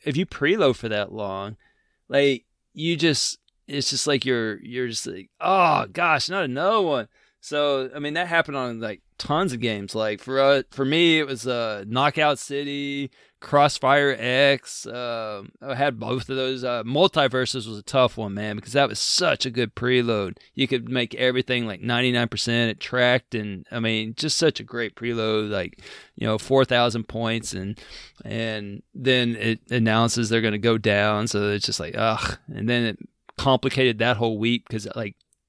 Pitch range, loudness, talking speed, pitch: 110-135 Hz, -23 LUFS, 185 wpm, 120 Hz